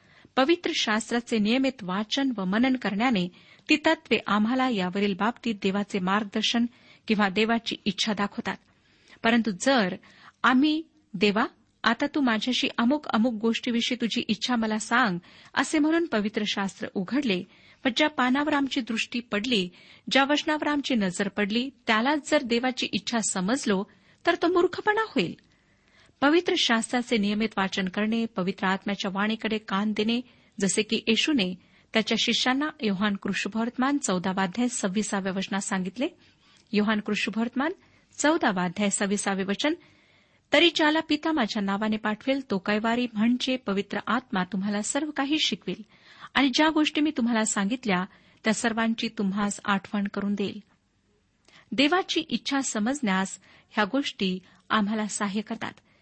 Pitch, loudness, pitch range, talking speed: 225 Hz, -26 LUFS, 205-265 Hz, 125 wpm